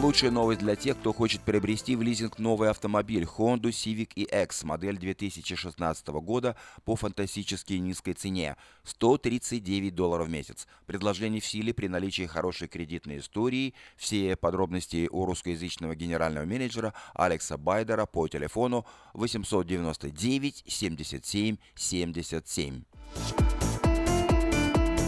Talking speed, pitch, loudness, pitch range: 110 wpm, 100 Hz, -30 LUFS, 85-110 Hz